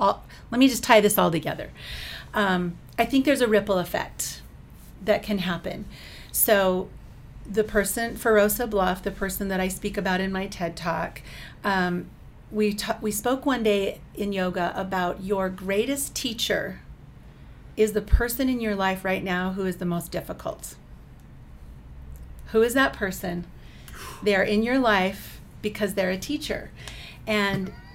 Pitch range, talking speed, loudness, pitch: 185-215 Hz, 155 wpm, -25 LUFS, 195 Hz